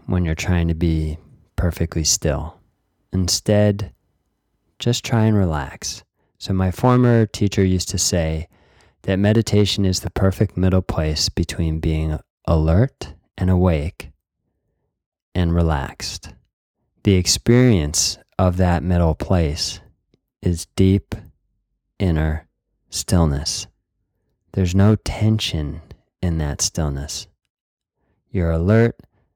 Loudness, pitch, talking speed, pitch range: -20 LUFS, 90 Hz, 105 wpm, 80-100 Hz